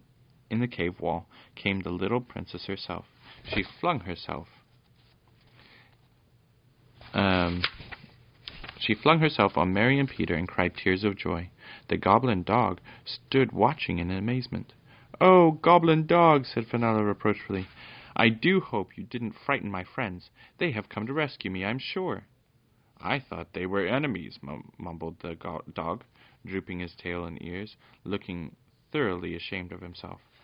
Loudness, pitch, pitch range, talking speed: -27 LUFS, 110 Hz, 90-125 Hz, 145 wpm